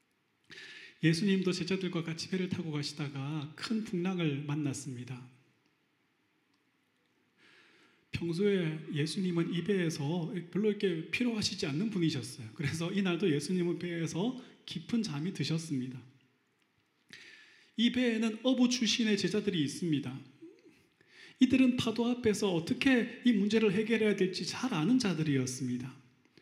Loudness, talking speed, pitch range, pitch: -32 LUFS, 285 characters per minute, 150-220 Hz, 180 Hz